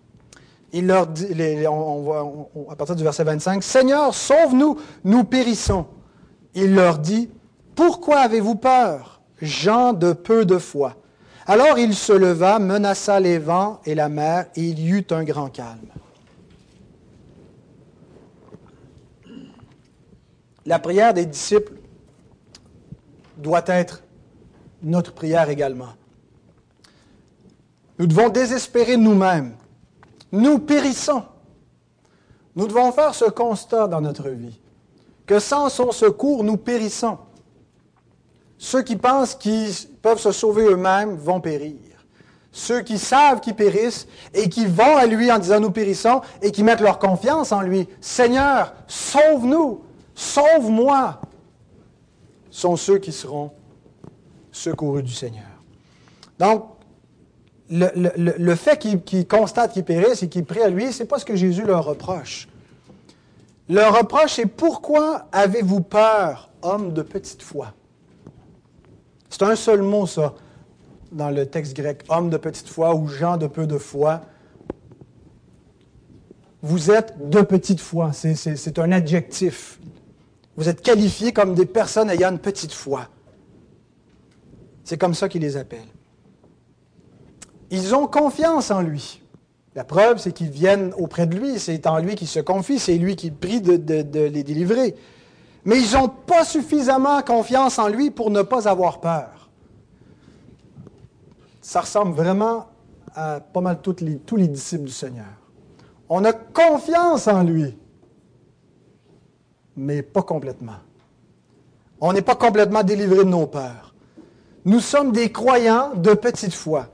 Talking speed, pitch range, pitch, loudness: 140 wpm, 160-230 Hz, 190 Hz, -19 LUFS